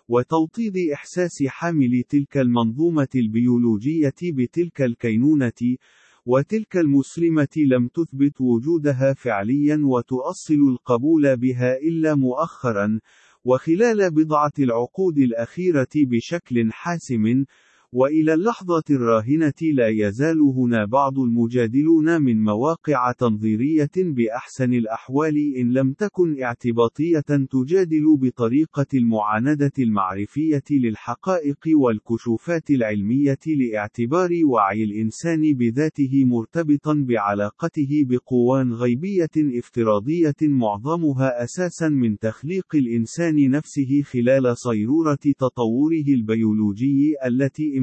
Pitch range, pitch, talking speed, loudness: 120-155 Hz, 135 Hz, 85 wpm, -20 LUFS